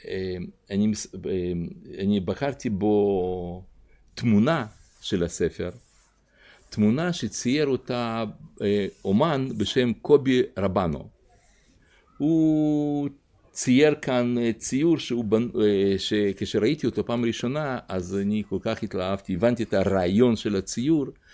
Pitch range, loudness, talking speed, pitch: 95-125 Hz, -25 LUFS, 95 wpm, 110 Hz